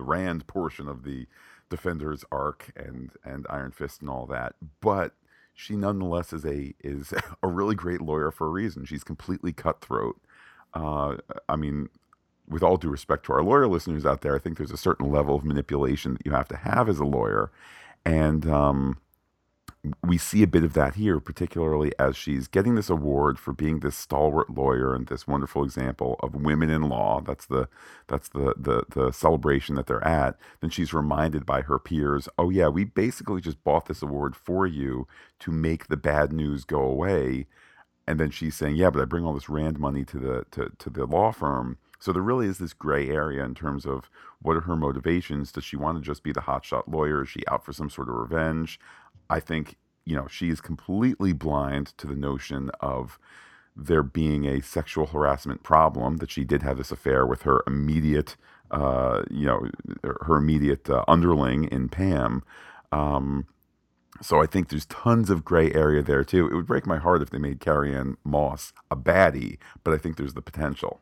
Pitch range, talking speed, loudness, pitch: 70-80 Hz, 200 wpm, -26 LUFS, 75 Hz